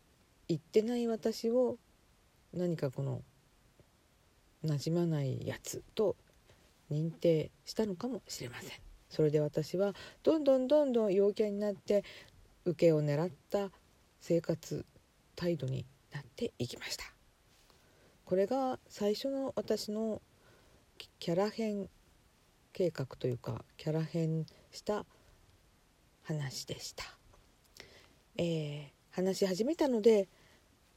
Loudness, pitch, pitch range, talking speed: -35 LUFS, 175 Hz, 150-210 Hz, 205 characters per minute